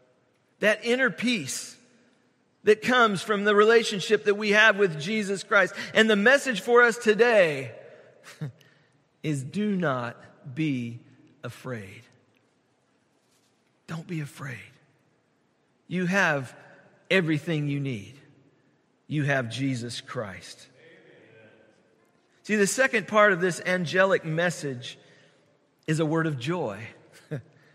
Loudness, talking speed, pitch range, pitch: -24 LUFS, 110 wpm, 140-210 Hz, 160 Hz